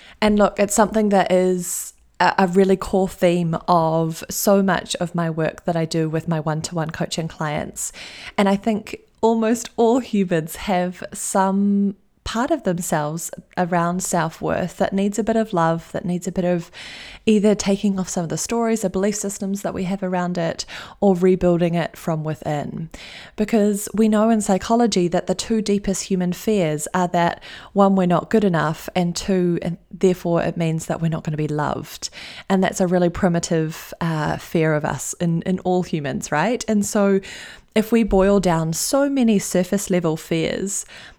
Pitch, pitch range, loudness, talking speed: 185 Hz, 170-200 Hz, -20 LUFS, 185 wpm